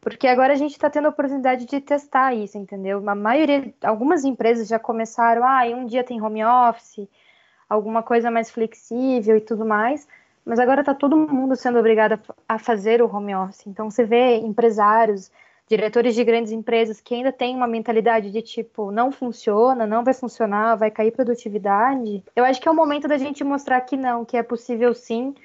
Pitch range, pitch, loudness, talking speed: 225-260 Hz, 235 Hz, -20 LUFS, 190 wpm